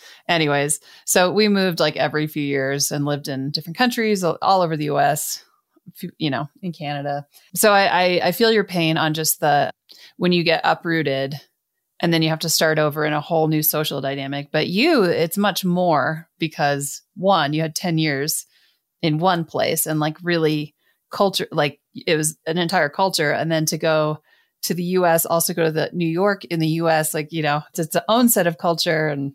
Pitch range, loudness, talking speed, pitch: 150-180 Hz, -20 LUFS, 205 wpm, 160 Hz